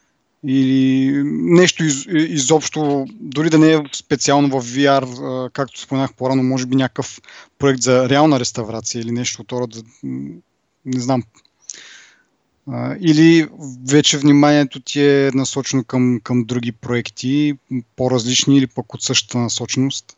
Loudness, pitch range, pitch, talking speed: -16 LUFS, 125-145 Hz, 130 Hz, 130 wpm